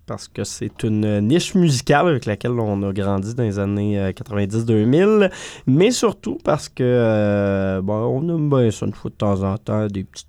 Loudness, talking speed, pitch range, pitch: -19 LUFS, 195 wpm, 100-145 Hz, 110 Hz